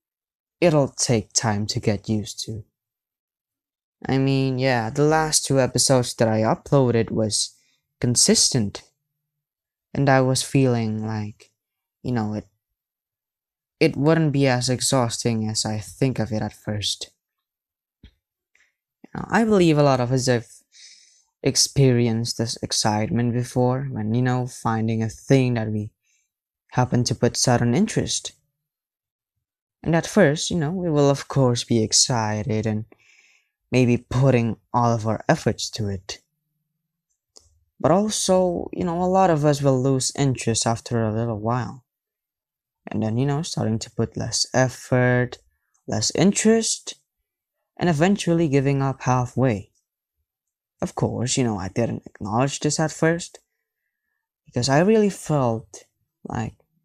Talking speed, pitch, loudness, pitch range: 140 wpm, 125 Hz, -21 LUFS, 110-145 Hz